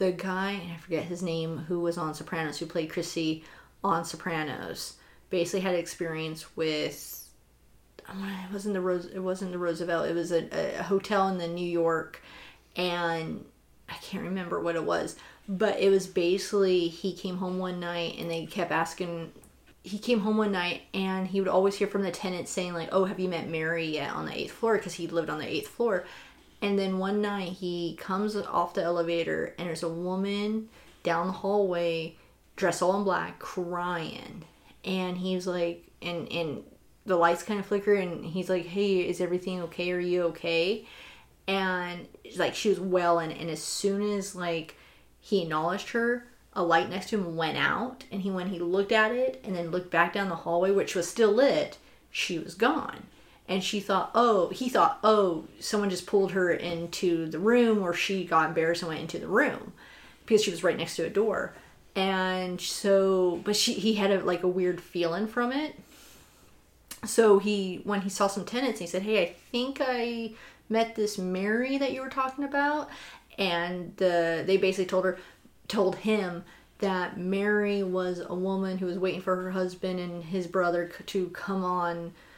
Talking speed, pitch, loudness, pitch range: 190 wpm, 185 Hz, -29 LUFS, 170-200 Hz